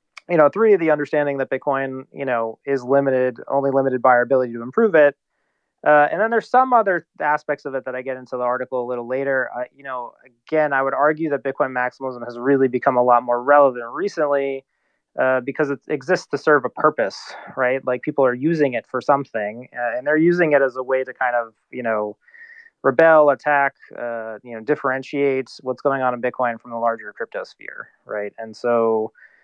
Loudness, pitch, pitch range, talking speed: -20 LUFS, 135 Hz, 125-150 Hz, 210 wpm